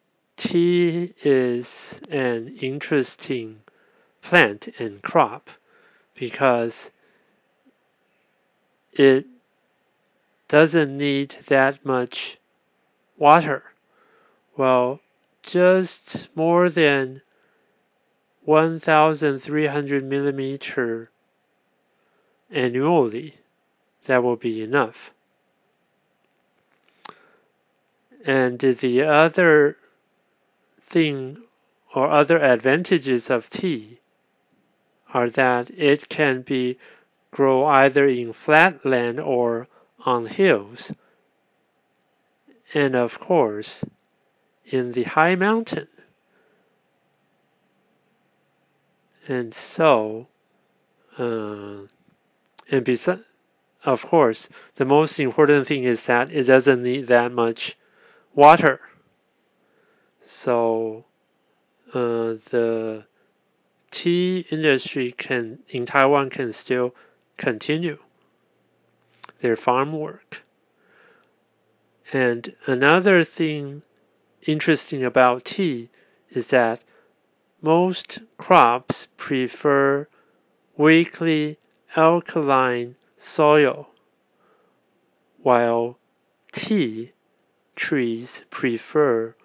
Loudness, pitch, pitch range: -20 LUFS, 135 Hz, 125-155 Hz